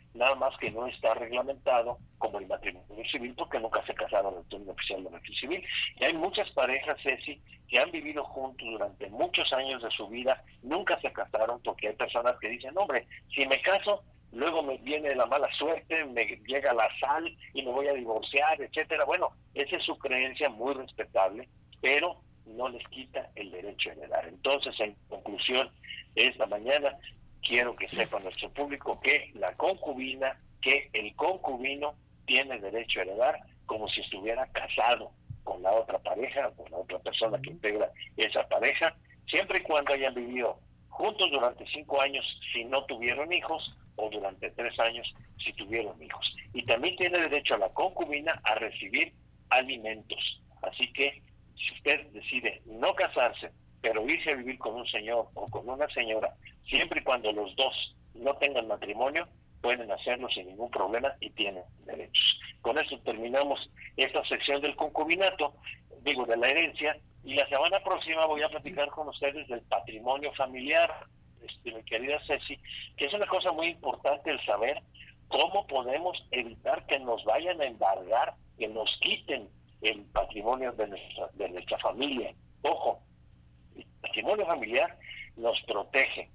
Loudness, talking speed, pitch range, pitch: -30 LUFS, 165 wpm, 115-145 Hz, 130 Hz